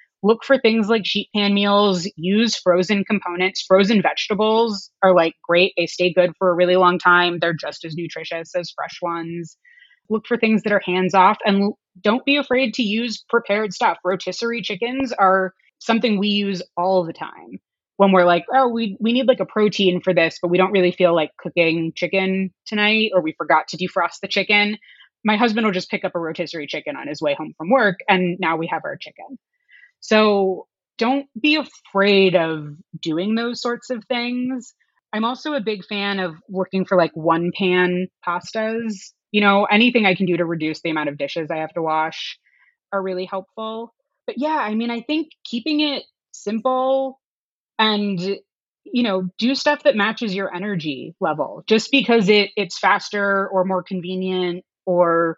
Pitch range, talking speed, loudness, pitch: 180-230 Hz, 185 wpm, -19 LUFS, 200 Hz